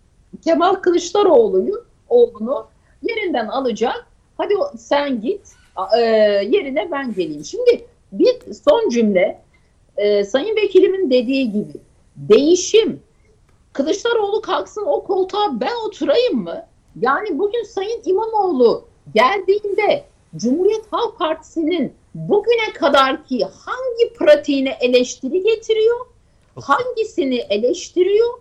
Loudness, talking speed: -18 LUFS, 95 wpm